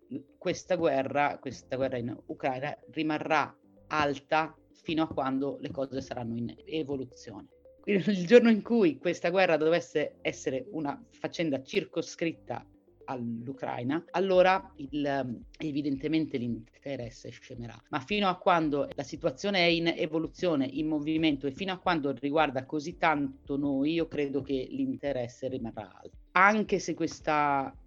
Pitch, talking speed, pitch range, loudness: 155 Hz, 130 wpm, 135-170 Hz, -30 LUFS